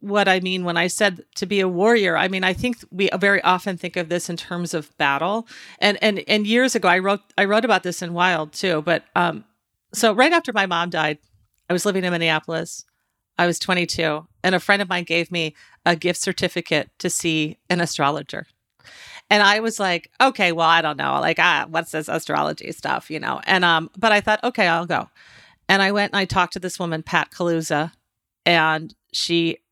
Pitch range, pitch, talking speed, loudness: 165-200 Hz, 180 Hz, 215 wpm, -20 LUFS